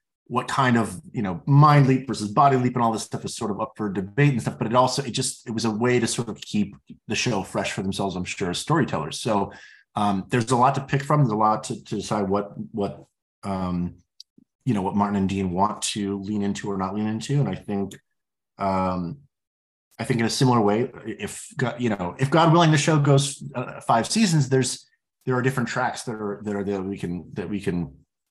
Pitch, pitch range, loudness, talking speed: 115 Hz, 100-130 Hz, -23 LUFS, 240 wpm